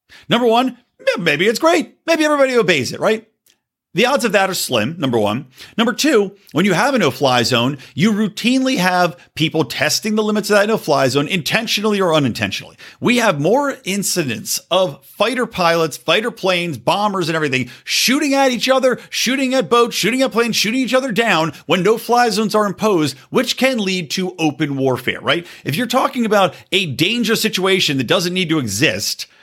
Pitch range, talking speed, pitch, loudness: 160-235 Hz, 190 wpm, 200 Hz, -16 LUFS